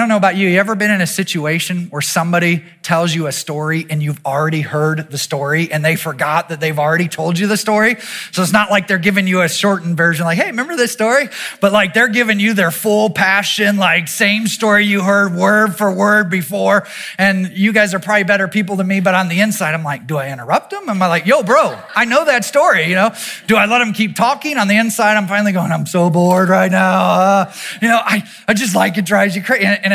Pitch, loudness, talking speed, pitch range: 195 Hz, -14 LUFS, 245 wpm, 170-210 Hz